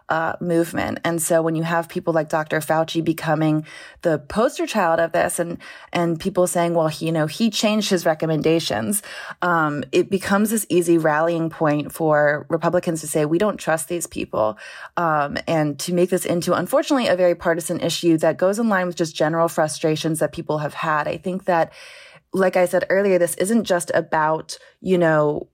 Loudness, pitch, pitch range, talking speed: -20 LUFS, 170 Hz, 160-180 Hz, 190 wpm